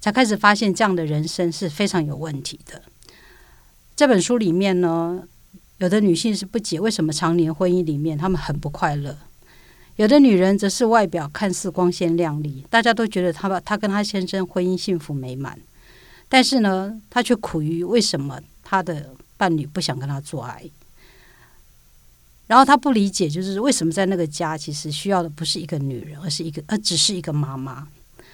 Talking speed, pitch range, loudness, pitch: 285 characters per minute, 155-200 Hz, -20 LUFS, 175 Hz